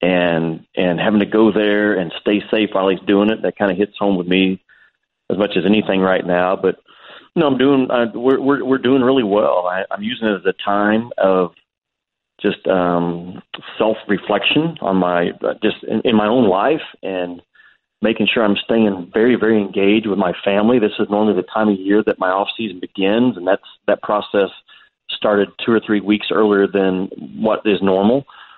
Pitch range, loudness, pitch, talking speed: 95-110 Hz, -17 LUFS, 105 Hz, 205 wpm